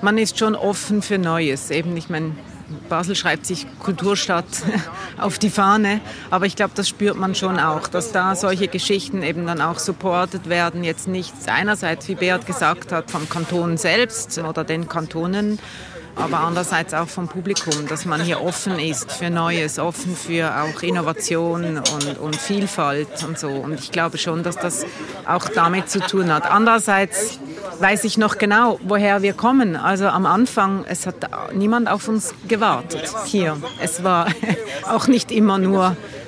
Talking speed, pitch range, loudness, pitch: 170 wpm, 165-200 Hz, -20 LUFS, 180 Hz